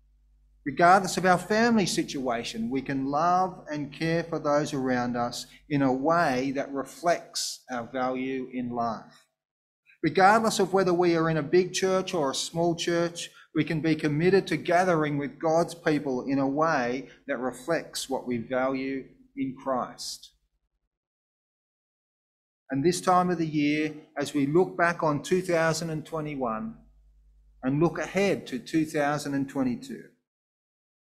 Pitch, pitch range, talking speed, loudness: 150 Hz, 130-170 Hz, 140 wpm, -27 LUFS